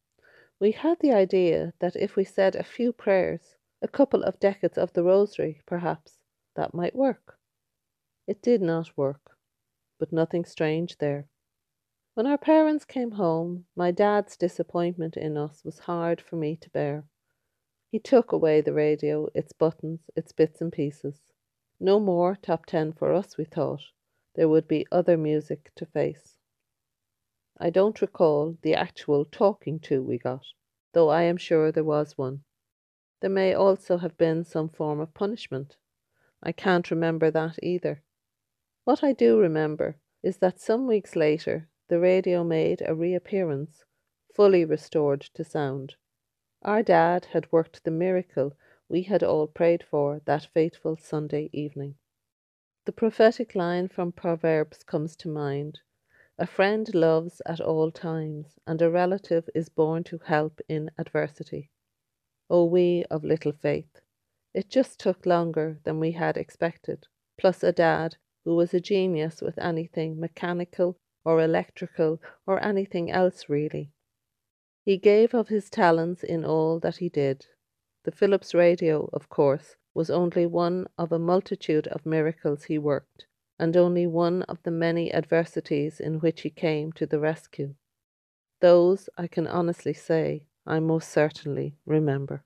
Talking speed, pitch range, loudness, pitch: 155 wpm, 150-180 Hz, -26 LUFS, 165 Hz